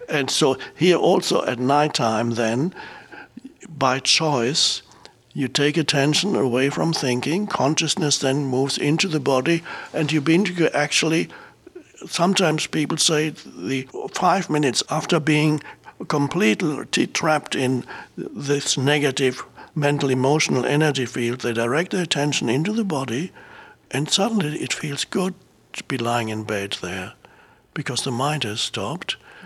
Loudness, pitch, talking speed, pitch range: -21 LUFS, 145 Hz, 135 wpm, 130-160 Hz